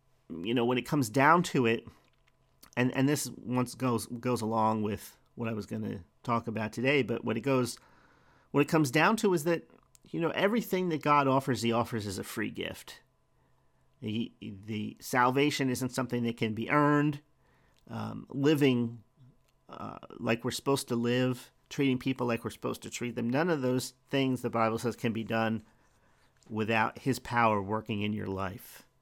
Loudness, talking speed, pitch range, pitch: -30 LUFS, 185 wpm, 115-135 Hz, 125 Hz